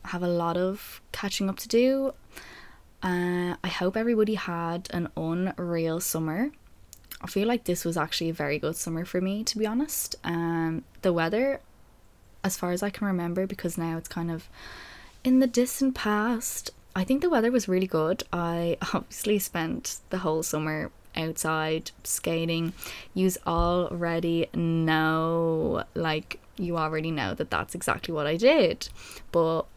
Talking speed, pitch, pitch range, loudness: 155 wpm, 175 Hz, 165-205 Hz, -28 LUFS